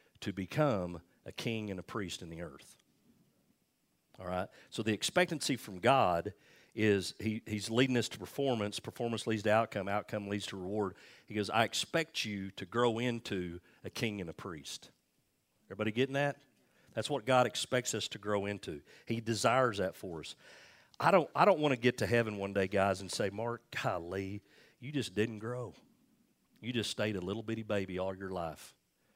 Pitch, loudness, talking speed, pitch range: 110 Hz, -34 LUFS, 185 wpm, 100-120 Hz